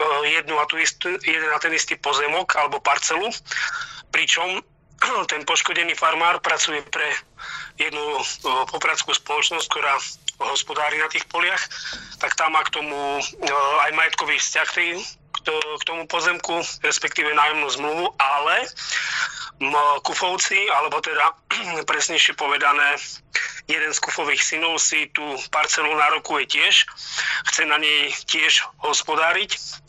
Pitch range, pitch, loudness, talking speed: 150-170 Hz, 155 Hz, -20 LUFS, 120 wpm